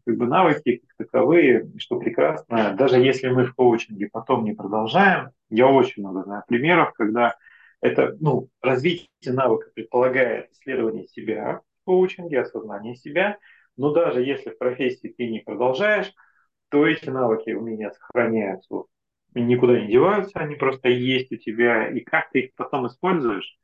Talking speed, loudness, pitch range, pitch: 150 wpm, -21 LUFS, 115-145 Hz, 125 Hz